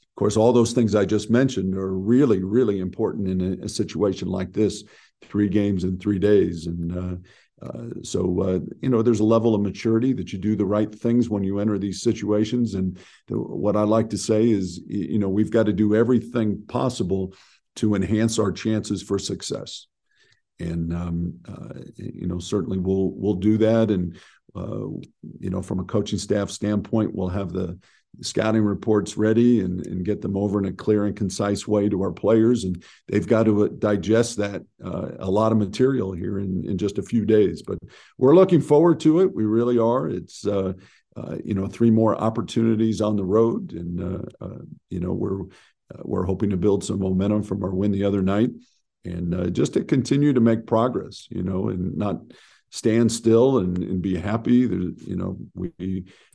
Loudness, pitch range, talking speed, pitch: -22 LUFS, 95-110 Hz, 195 wpm, 105 Hz